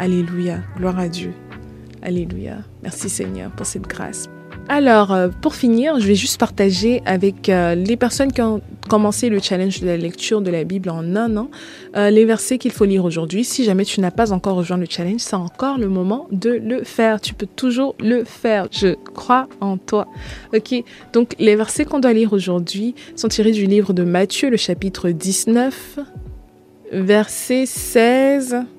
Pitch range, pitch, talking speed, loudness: 185-235 Hz, 210 Hz, 175 wpm, -18 LUFS